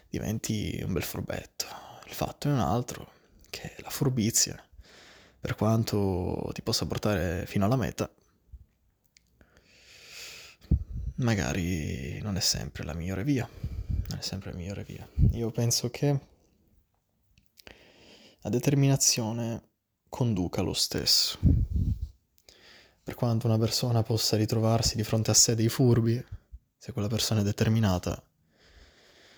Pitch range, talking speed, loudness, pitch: 95-115 Hz, 120 wpm, -28 LUFS, 105 Hz